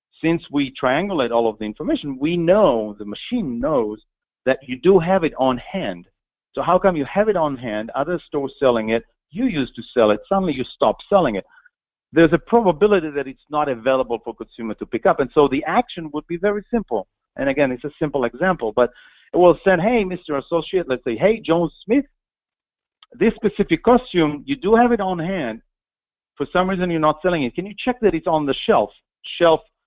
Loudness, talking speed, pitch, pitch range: -20 LUFS, 210 wpm, 165 Hz, 135-200 Hz